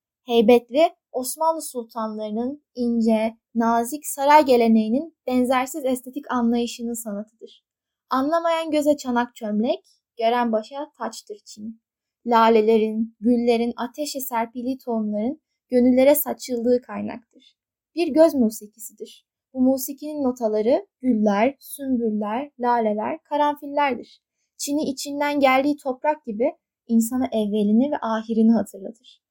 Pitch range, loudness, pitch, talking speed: 225-285 Hz, -22 LUFS, 245 Hz, 95 wpm